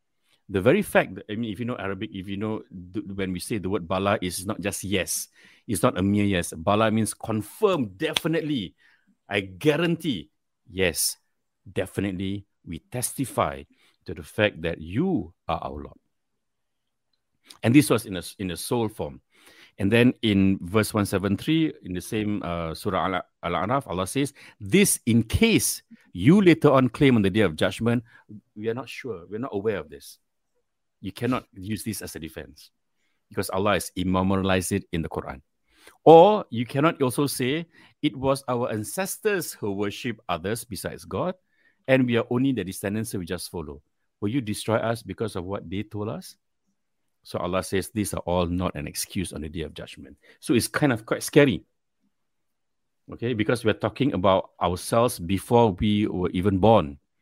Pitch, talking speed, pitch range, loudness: 105 Hz, 175 wpm, 95-125 Hz, -25 LUFS